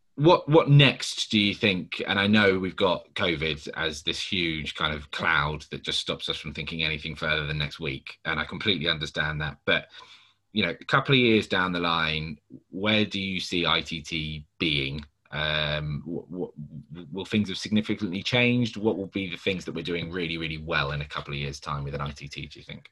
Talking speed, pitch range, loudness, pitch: 210 wpm, 75-100 Hz, -26 LUFS, 80 Hz